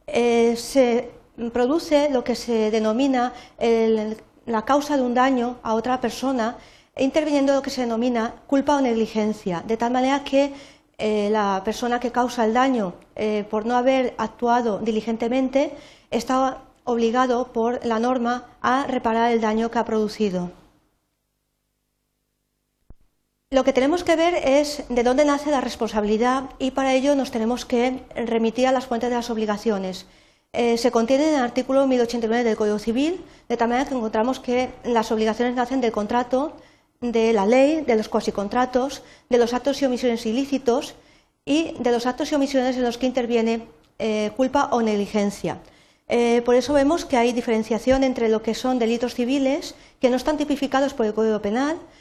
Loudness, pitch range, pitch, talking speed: -22 LUFS, 230-265 Hz, 245 Hz, 165 wpm